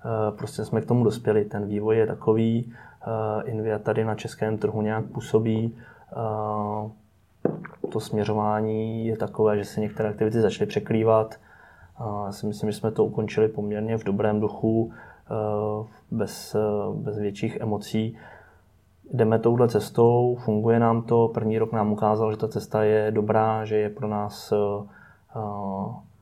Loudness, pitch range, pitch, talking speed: -25 LUFS, 105-110 Hz, 110 Hz, 135 wpm